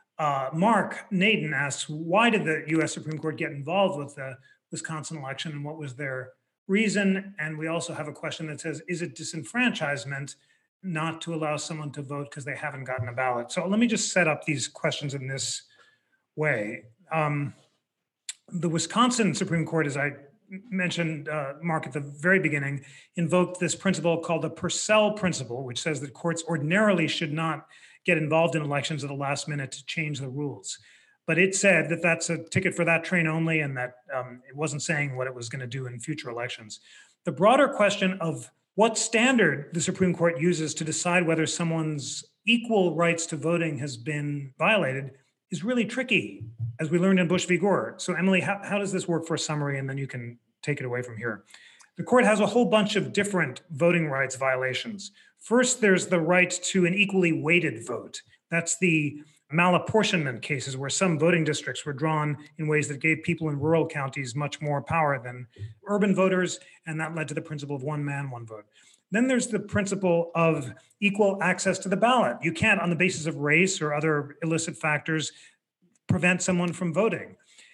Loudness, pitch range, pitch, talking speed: -26 LUFS, 145-180 Hz, 160 Hz, 195 wpm